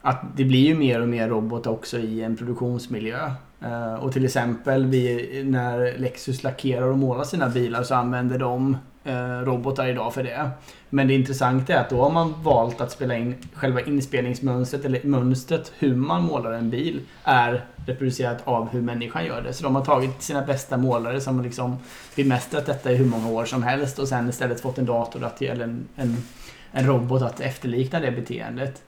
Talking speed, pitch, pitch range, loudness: 195 wpm, 125 Hz, 120-135 Hz, -24 LUFS